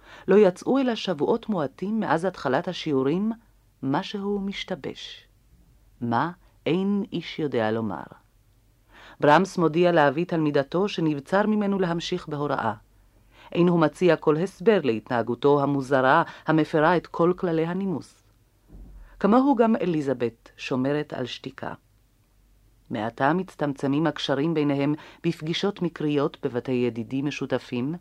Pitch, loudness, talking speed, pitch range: 150 Hz, -24 LUFS, 110 wpm, 130-185 Hz